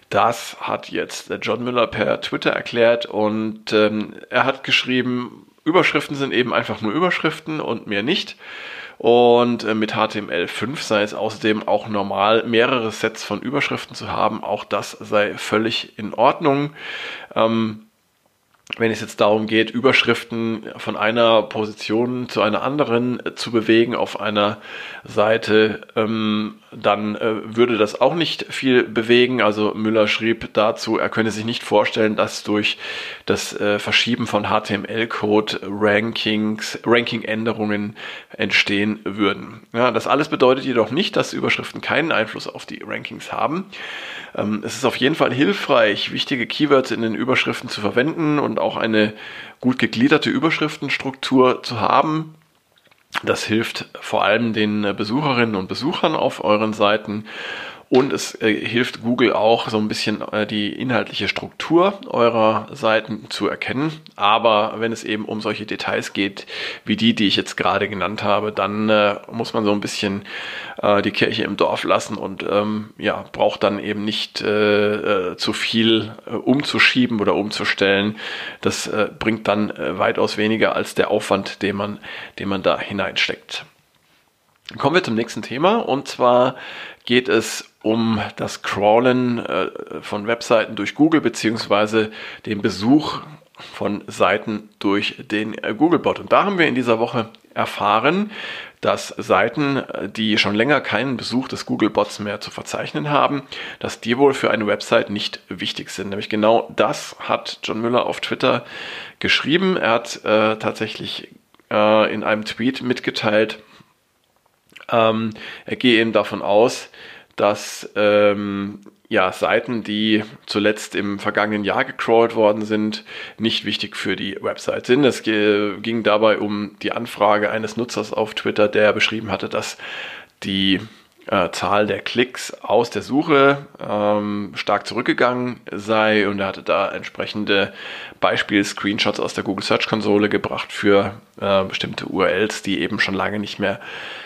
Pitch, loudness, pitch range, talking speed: 110 Hz, -19 LUFS, 105-120 Hz, 150 wpm